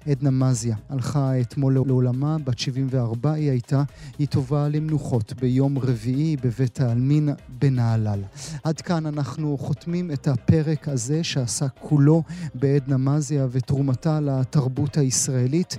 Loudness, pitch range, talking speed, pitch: -23 LUFS, 130-150 Hz, 120 wpm, 140 Hz